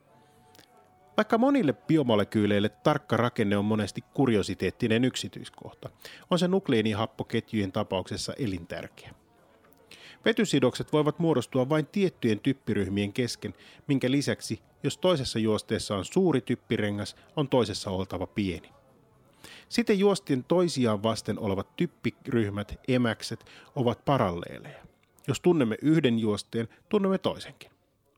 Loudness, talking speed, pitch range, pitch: -28 LUFS, 100 wpm, 105-150 Hz, 120 Hz